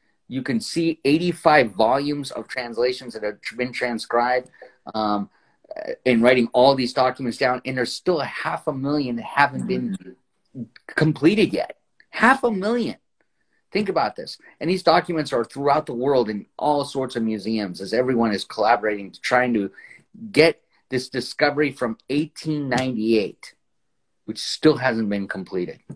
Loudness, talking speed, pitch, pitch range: -22 LUFS, 150 wpm, 125 Hz, 115-150 Hz